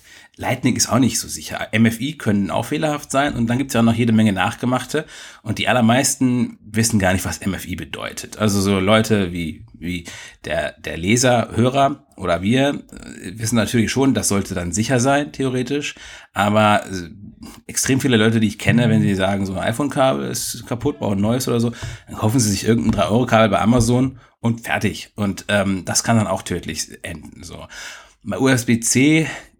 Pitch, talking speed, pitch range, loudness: 115 Hz, 180 wpm, 100-125 Hz, -19 LUFS